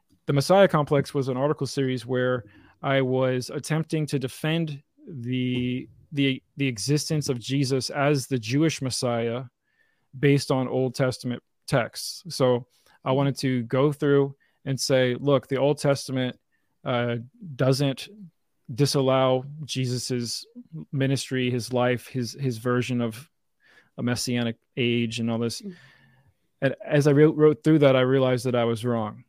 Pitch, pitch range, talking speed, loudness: 135 Hz, 125-145 Hz, 145 wpm, -25 LUFS